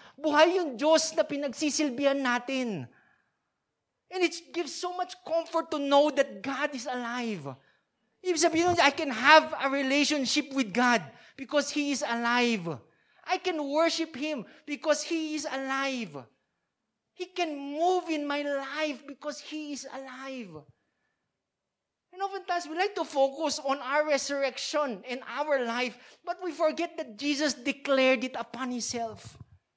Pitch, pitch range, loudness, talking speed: 285 Hz, 260-315 Hz, -28 LUFS, 135 wpm